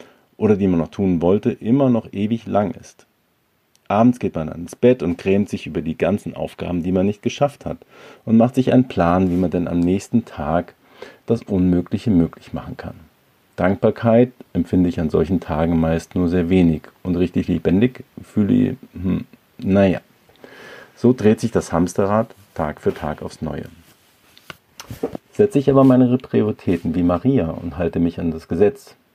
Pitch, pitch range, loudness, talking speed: 95 Hz, 85-115 Hz, -19 LUFS, 175 wpm